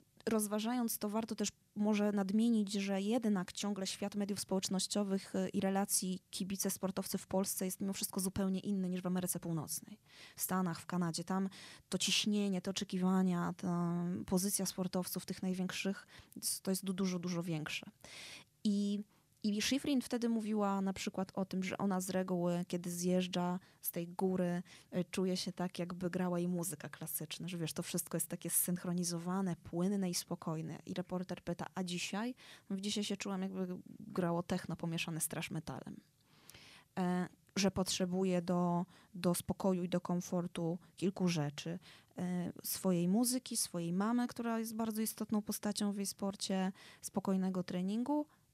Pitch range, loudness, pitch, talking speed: 175-200 Hz, -38 LUFS, 185 Hz, 150 wpm